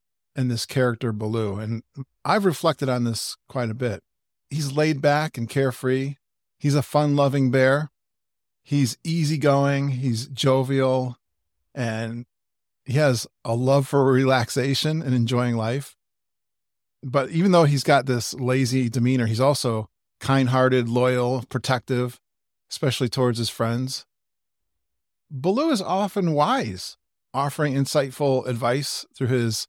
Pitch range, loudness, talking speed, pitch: 115-140 Hz, -23 LUFS, 125 wpm, 130 Hz